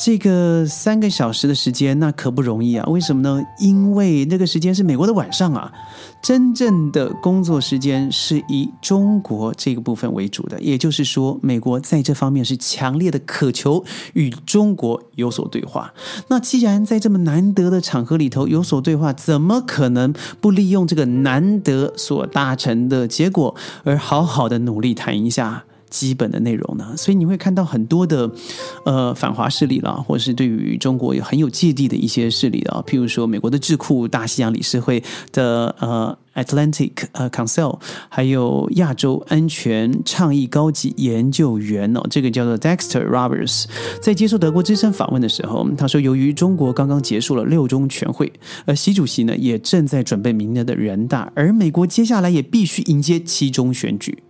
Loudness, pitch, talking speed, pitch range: -18 LUFS, 140 Hz, 305 characters per minute, 125-175 Hz